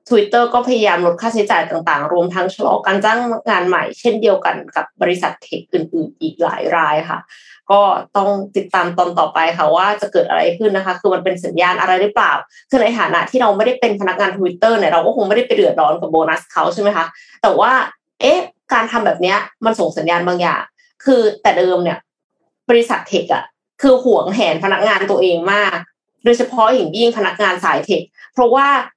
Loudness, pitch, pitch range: -15 LUFS, 205 Hz, 180-240 Hz